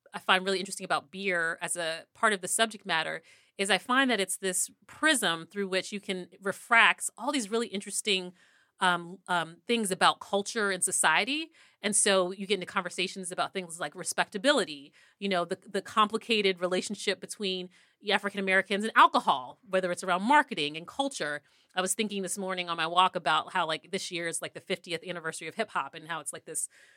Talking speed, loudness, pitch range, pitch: 195 wpm, -29 LUFS, 180-205 Hz, 190 Hz